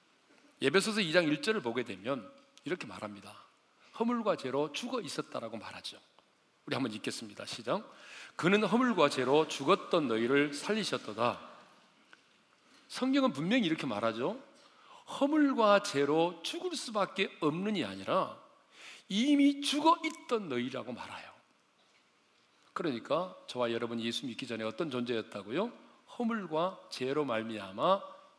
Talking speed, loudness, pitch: 285 characters per minute, -32 LUFS, 180 Hz